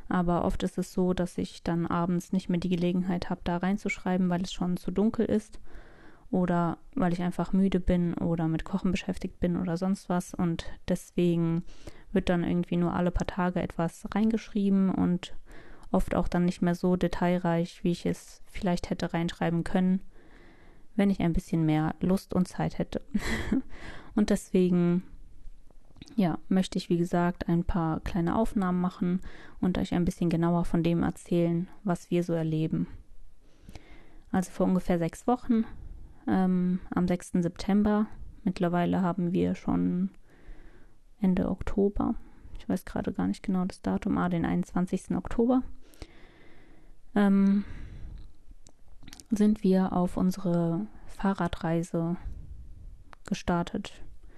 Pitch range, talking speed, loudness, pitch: 170-195 Hz, 140 wpm, -29 LUFS, 180 Hz